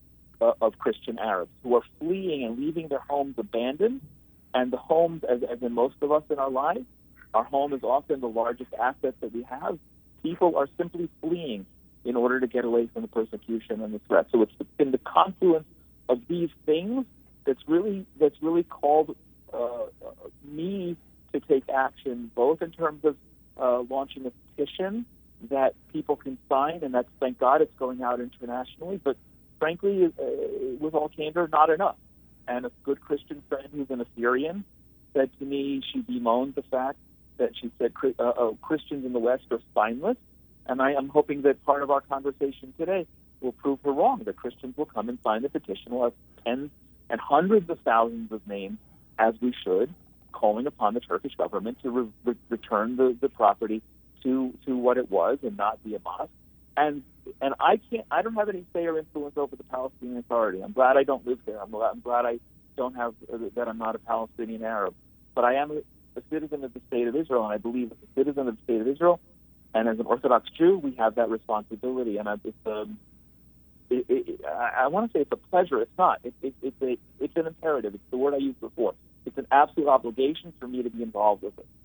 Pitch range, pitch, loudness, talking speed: 120-155 Hz, 135 Hz, -27 LUFS, 205 wpm